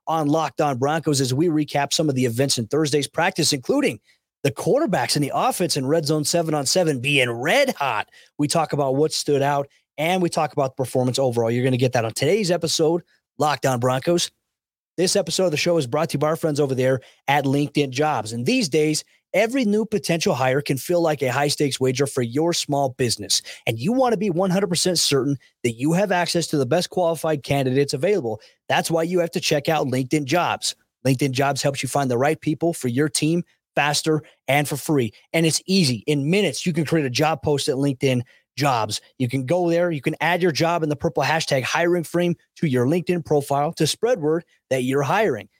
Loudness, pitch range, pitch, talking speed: -21 LUFS, 140-170 Hz, 150 Hz, 220 wpm